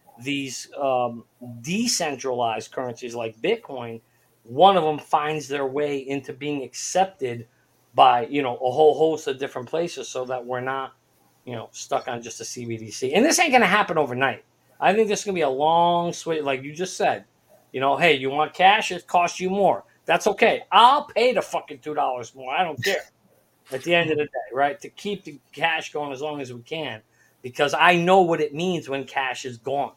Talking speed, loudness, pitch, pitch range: 210 wpm, -22 LUFS, 145 Hz, 130-170 Hz